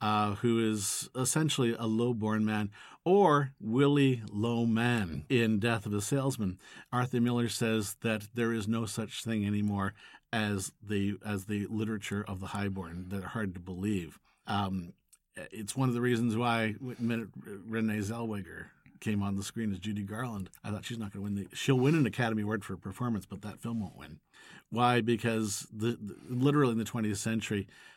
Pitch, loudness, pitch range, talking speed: 110 Hz, -32 LUFS, 100-120 Hz, 180 wpm